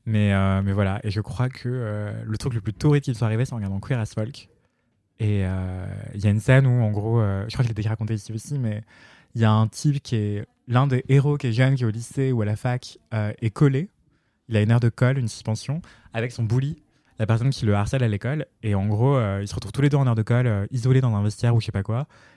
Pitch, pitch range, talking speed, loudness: 115 Hz, 105-130 Hz, 300 wpm, -23 LUFS